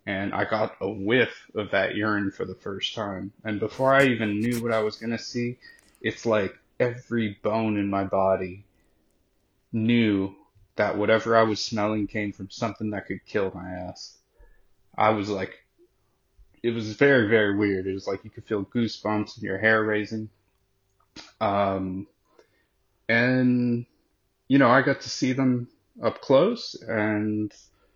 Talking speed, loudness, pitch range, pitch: 160 wpm, -25 LUFS, 100-115 Hz, 105 Hz